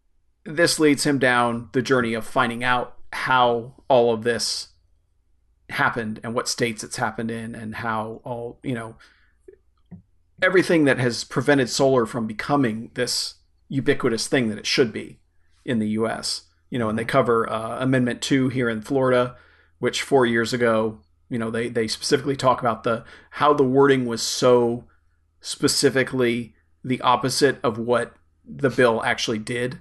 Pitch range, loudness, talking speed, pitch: 110-130 Hz, -22 LUFS, 160 wpm, 120 Hz